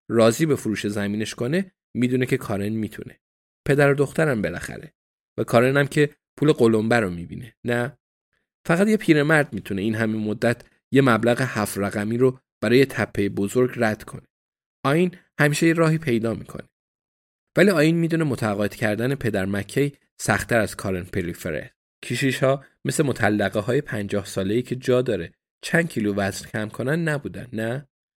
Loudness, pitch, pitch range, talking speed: -22 LUFS, 120 Hz, 105-140 Hz, 160 wpm